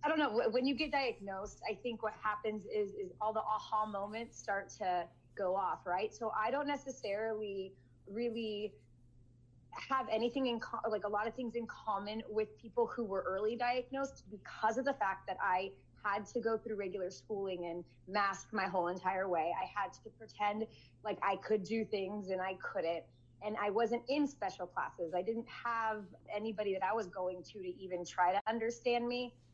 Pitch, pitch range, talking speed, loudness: 210 Hz, 190-230 Hz, 195 wpm, -38 LUFS